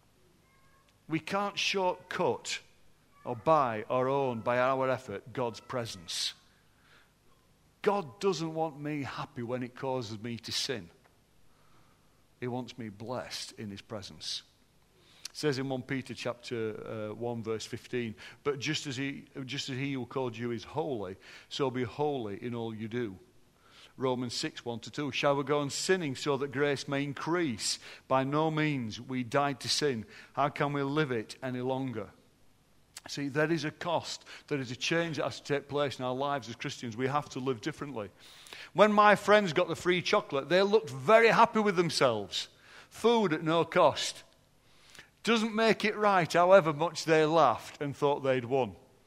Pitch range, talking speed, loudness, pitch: 125-160 Hz, 170 wpm, -31 LUFS, 140 Hz